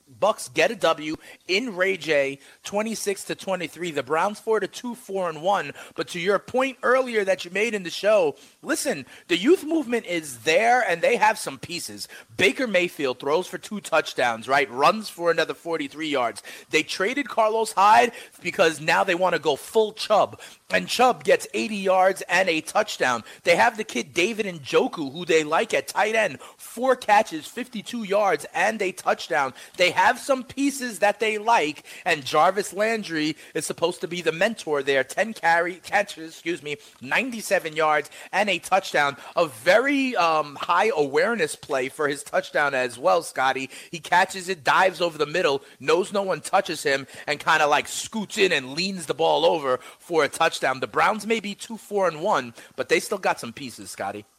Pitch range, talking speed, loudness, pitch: 160-220 Hz, 190 wpm, -23 LUFS, 190 Hz